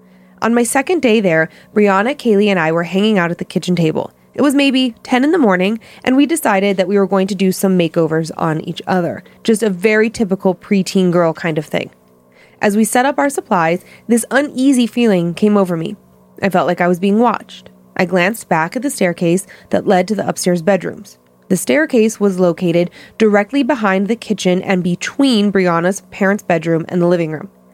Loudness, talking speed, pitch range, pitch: -15 LUFS, 205 wpm, 175-220 Hz, 195 Hz